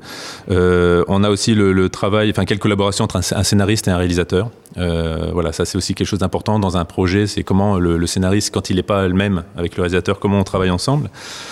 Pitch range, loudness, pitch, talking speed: 90-100 Hz, -17 LUFS, 95 Hz, 235 wpm